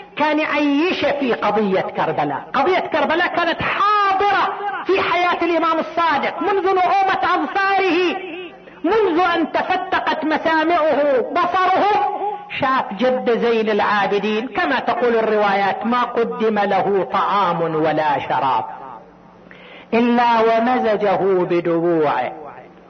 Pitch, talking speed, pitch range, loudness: 295 Hz, 95 wpm, 220-360 Hz, -18 LUFS